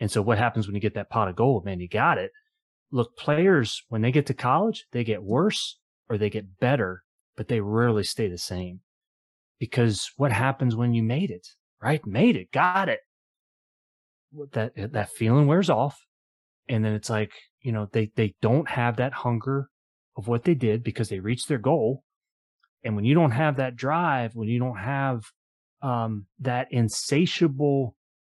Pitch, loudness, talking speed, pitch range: 120 Hz, -25 LUFS, 185 wpm, 110-140 Hz